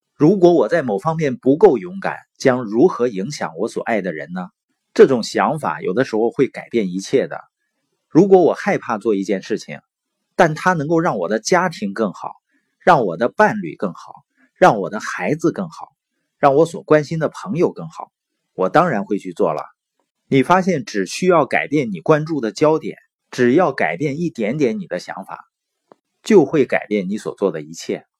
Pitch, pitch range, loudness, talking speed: 150 Hz, 105-175 Hz, -18 LUFS, 260 characters per minute